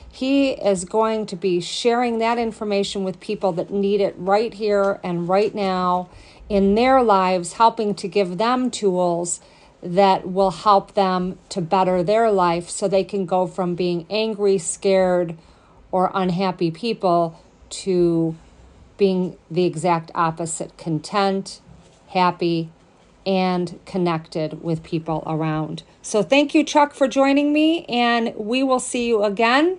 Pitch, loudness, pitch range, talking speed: 195 Hz, -20 LUFS, 175-215 Hz, 140 wpm